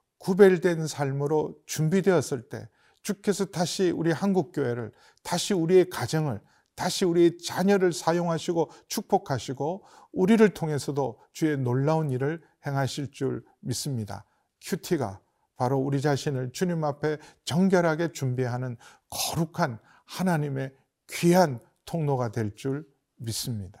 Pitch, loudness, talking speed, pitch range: 150 Hz, -27 LUFS, 280 characters per minute, 135-175 Hz